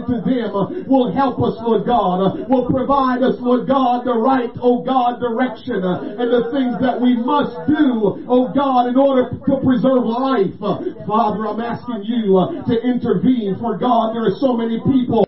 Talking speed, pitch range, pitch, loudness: 175 wpm, 225-260 Hz, 245 Hz, -17 LUFS